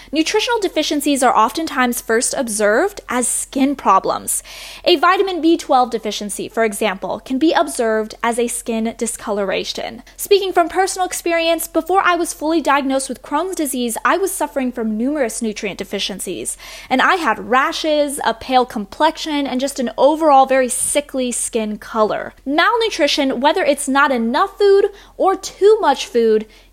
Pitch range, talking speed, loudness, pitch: 230-330 Hz, 150 wpm, -17 LUFS, 275 Hz